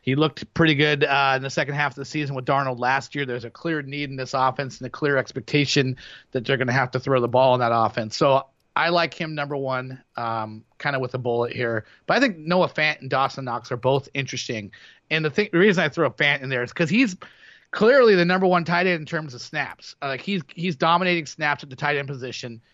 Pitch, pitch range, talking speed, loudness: 140 Hz, 130-155 Hz, 260 wpm, -22 LUFS